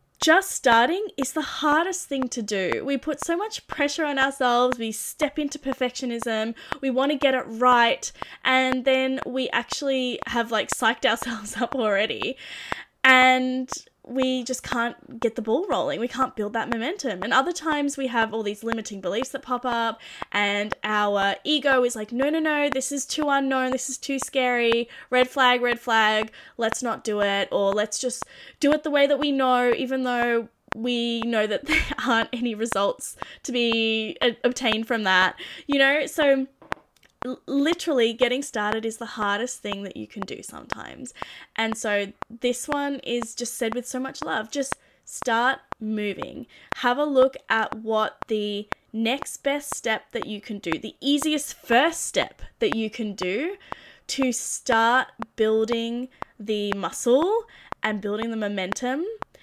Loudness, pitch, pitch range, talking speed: -24 LUFS, 245 Hz, 225-275 Hz, 170 wpm